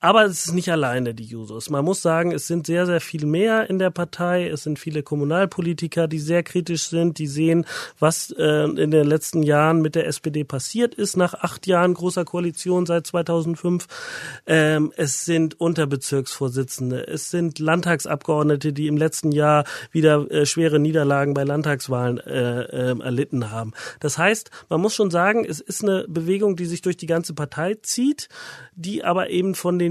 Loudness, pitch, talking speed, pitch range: -21 LUFS, 165 Hz, 180 wpm, 150-175 Hz